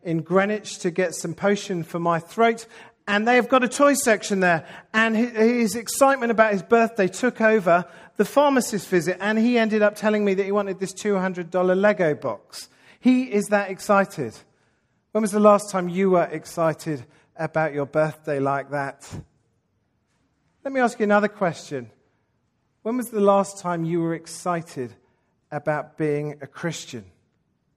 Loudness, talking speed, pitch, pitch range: -22 LUFS, 160 wpm, 185 Hz, 155-215 Hz